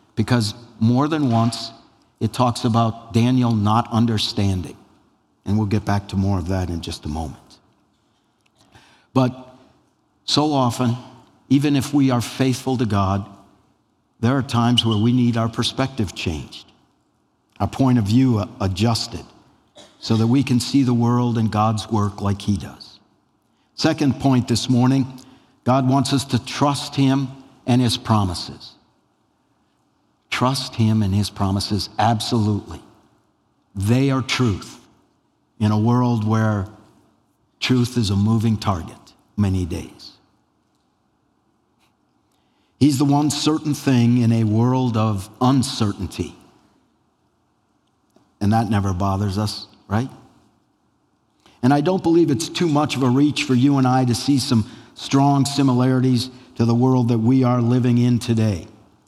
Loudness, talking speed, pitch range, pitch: -20 LUFS, 140 wpm, 105-130 Hz, 120 Hz